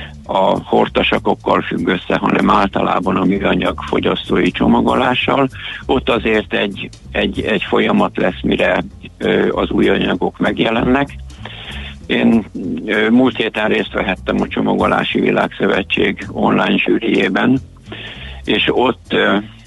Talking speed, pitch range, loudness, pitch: 105 wpm, 75-115 Hz, -15 LUFS, 100 Hz